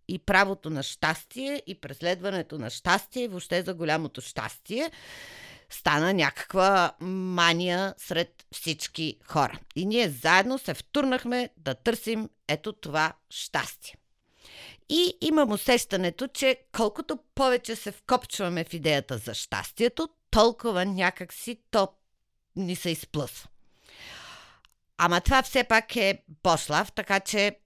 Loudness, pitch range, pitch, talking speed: -27 LUFS, 165-235 Hz, 190 Hz, 120 wpm